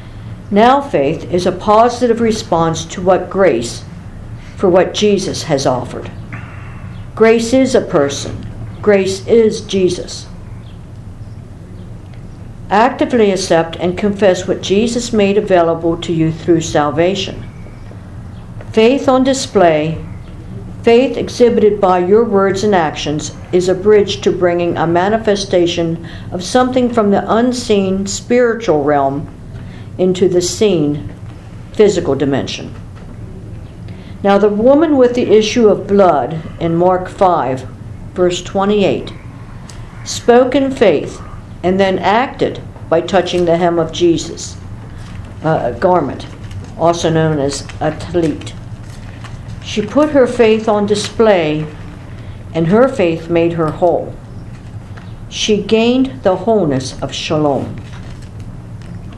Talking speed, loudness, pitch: 115 wpm, -13 LUFS, 170 Hz